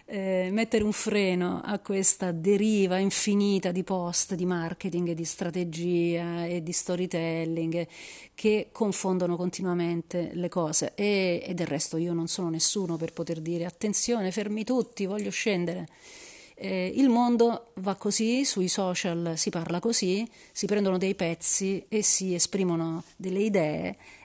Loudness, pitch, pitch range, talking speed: -25 LUFS, 185 Hz, 170-205 Hz, 140 wpm